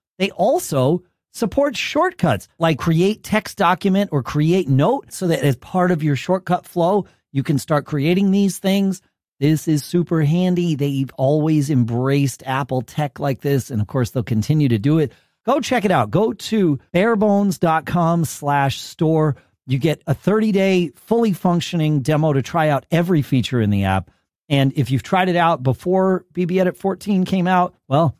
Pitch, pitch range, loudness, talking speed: 165 Hz, 140-185 Hz, -19 LUFS, 175 wpm